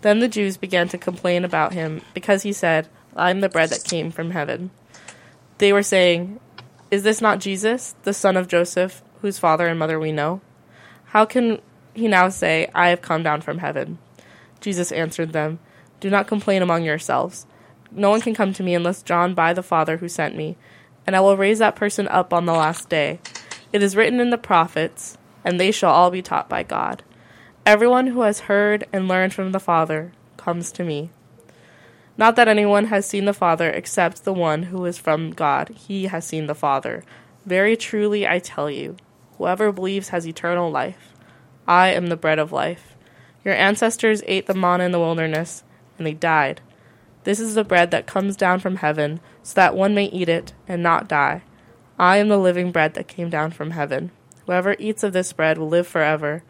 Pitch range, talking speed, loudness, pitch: 160-200 Hz, 200 wpm, -20 LUFS, 180 Hz